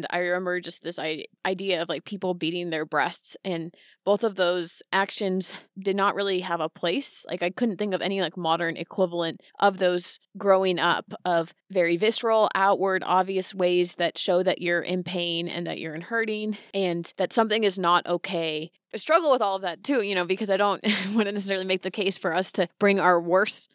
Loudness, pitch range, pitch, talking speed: -25 LUFS, 175-200 Hz, 185 Hz, 210 wpm